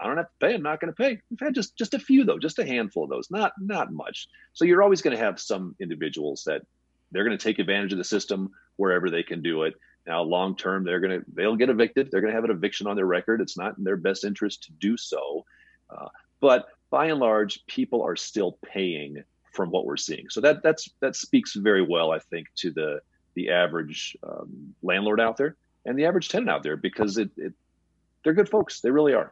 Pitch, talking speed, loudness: 115 Hz, 245 wpm, -25 LUFS